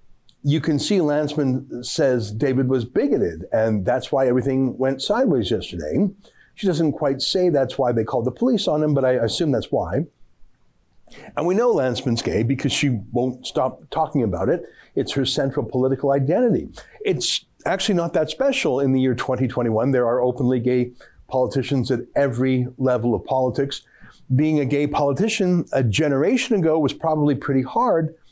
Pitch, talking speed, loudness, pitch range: 135 Hz, 165 wpm, -21 LUFS, 125-150 Hz